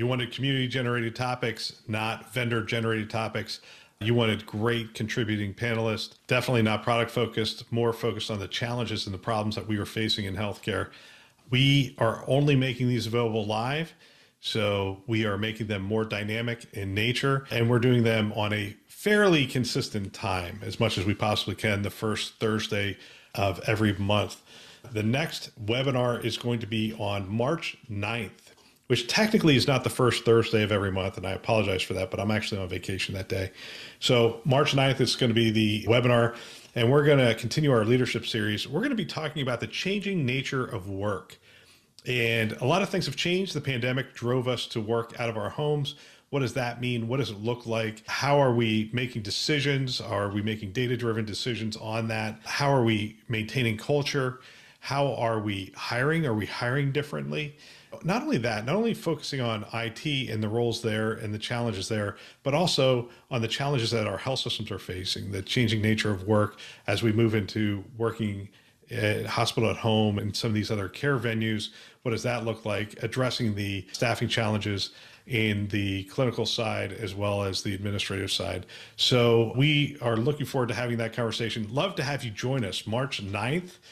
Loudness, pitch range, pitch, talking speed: -27 LUFS, 105-125 Hz, 115 Hz, 190 wpm